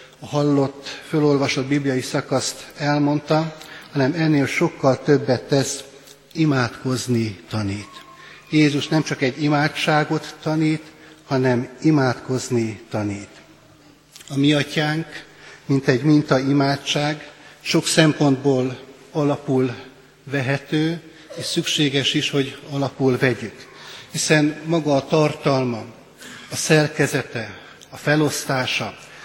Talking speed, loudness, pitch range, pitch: 95 wpm, -20 LUFS, 130-150 Hz, 140 Hz